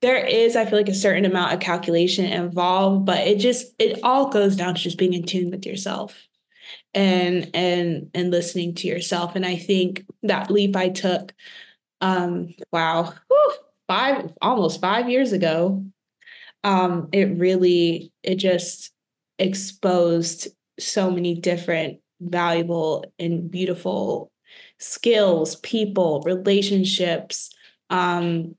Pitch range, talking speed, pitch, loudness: 175-200 Hz, 130 wpm, 185 Hz, -21 LUFS